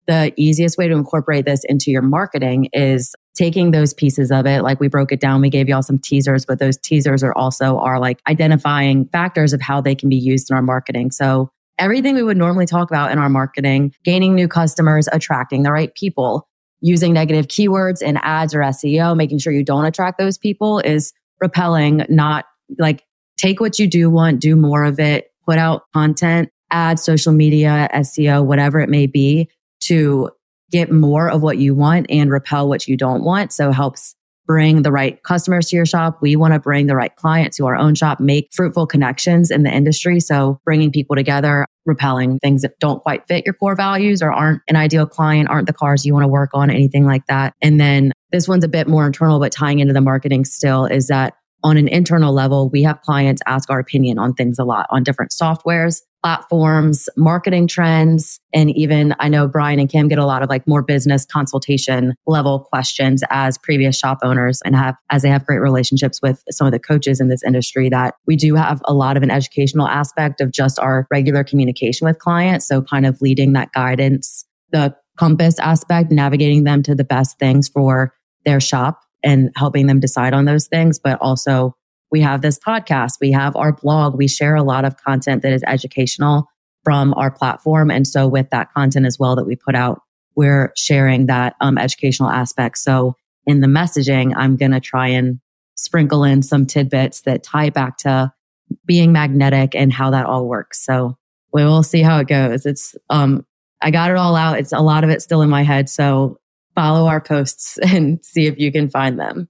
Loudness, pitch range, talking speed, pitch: -15 LUFS, 135-155 Hz, 205 wpm, 145 Hz